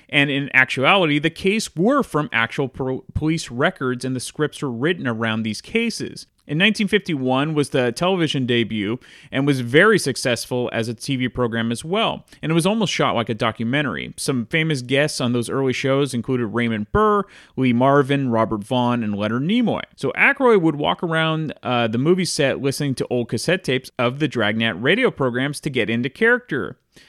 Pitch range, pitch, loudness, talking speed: 120-160 Hz, 135 Hz, -20 LUFS, 185 wpm